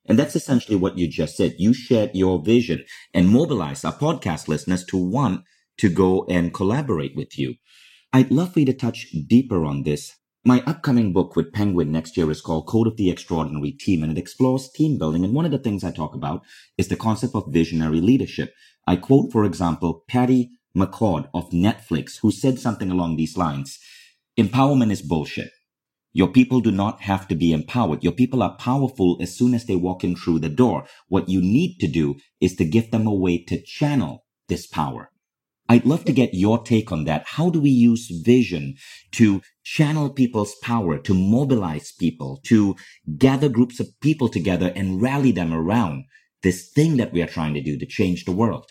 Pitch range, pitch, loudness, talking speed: 85-125 Hz, 100 Hz, -21 LUFS, 200 wpm